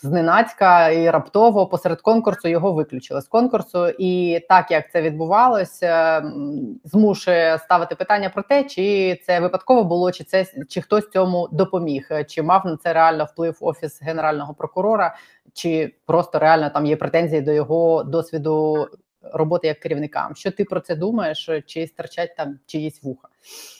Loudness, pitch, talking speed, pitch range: -19 LUFS, 170 Hz, 150 wpm, 155-190 Hz